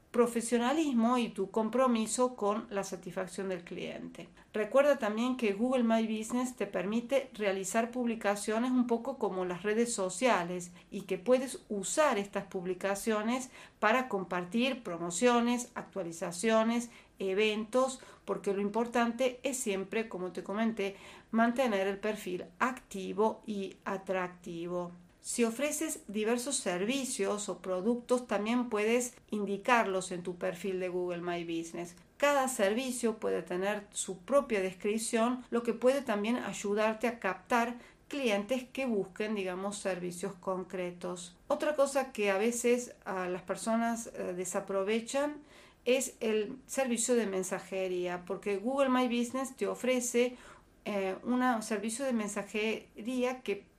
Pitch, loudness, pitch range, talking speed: 215 Hz, -33 LUFS, 195-245 Hz, 125 wpm